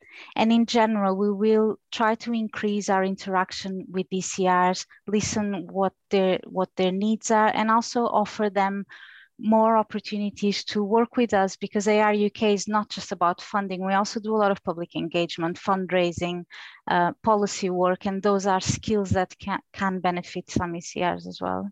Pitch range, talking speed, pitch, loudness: 185-215 Hz, 165 wpm, 200 Hz, -24 LUFS